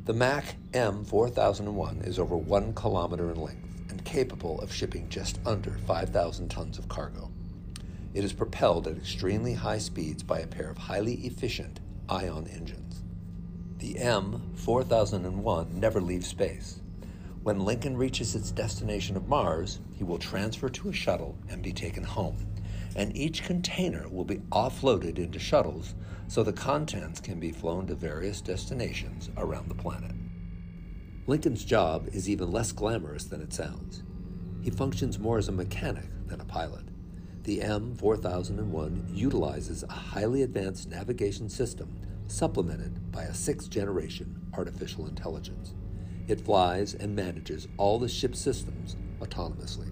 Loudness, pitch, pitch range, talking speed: -32 LUFS, 95 Hz, 90-100 Hz, 145 wpm